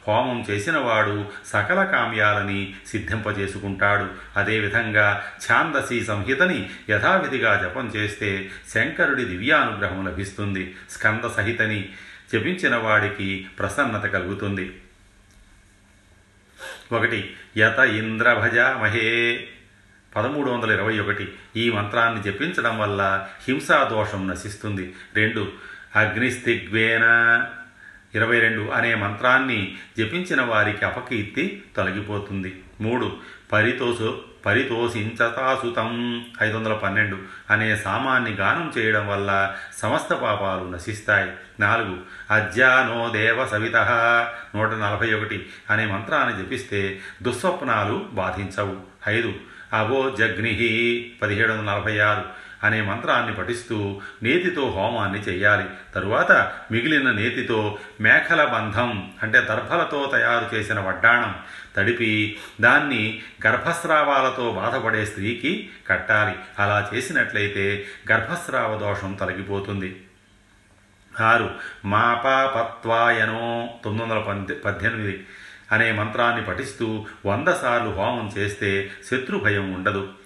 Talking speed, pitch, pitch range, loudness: 90 wpm, 105 Hz, 100-115 Hz, -22 LUFS